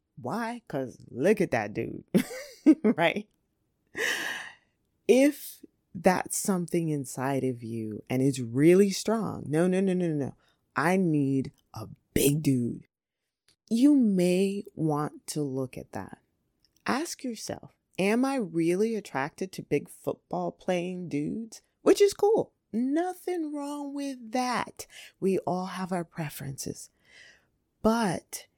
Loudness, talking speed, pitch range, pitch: -28 LUFS, 120 wpm, 145-230 Hz, 185 Hz